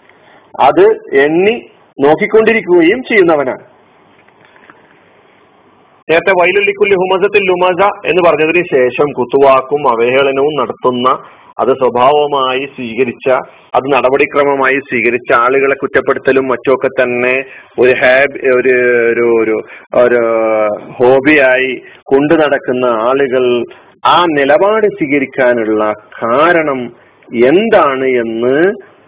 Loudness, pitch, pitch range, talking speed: -11 LUFS, 135 Hz, 125-160 Hz, 80 wpm